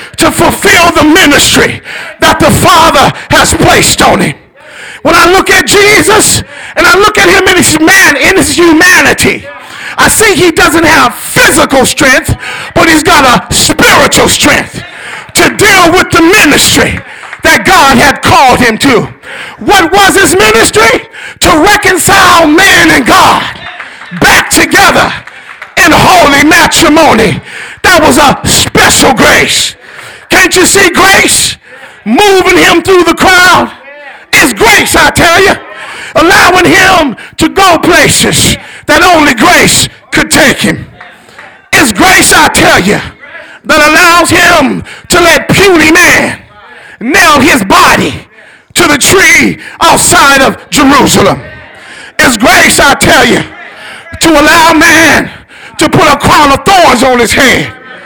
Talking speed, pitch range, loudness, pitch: 135 wpm, 320-375 Hz, -3 LUFS, 345 Hz